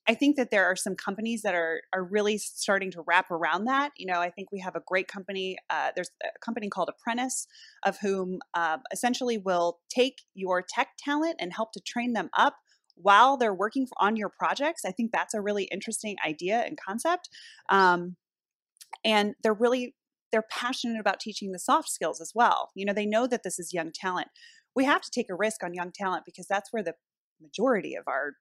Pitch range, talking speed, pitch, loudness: 185-245 Hz, 210 wpm, 210 Hz, -28 LUFS